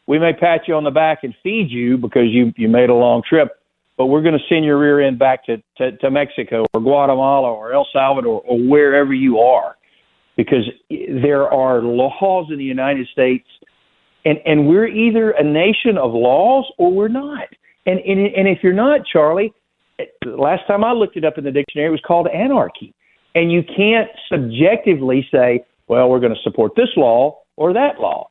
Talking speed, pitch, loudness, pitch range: 200 wpm, 150 Hz, -15 LUFS, 130-195 Hz